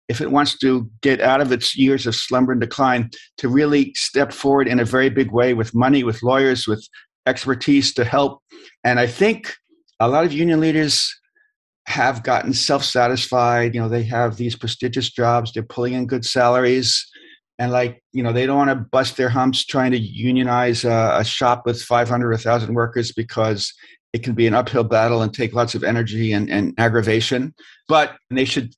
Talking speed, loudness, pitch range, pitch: 195 wpm, -18 LUFS, 120-135 Hz, 125 Hz